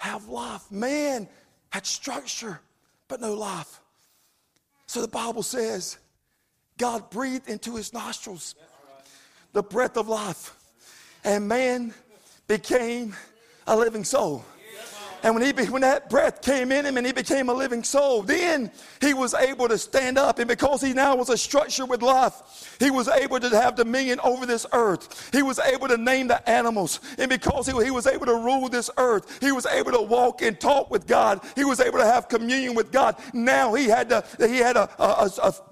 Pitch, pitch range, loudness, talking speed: 245 Hz, 225-265 Hz, -23 LUFS, 185 wpm